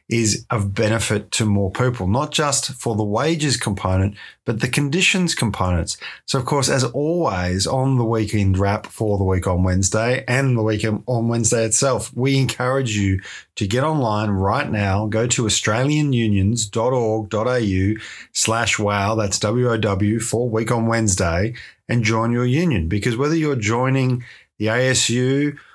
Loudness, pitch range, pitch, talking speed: -19 LUFS, 105-130 Hz, 115 Hz, 150 wpm